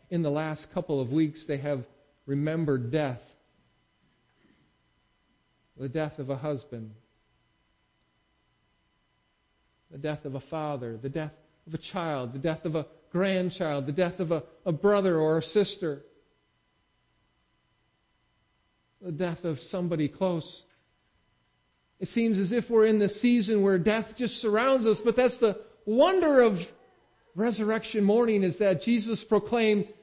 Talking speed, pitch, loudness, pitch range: 135 wpm, 170 Hz, -27 LUFS, 150-210 Hz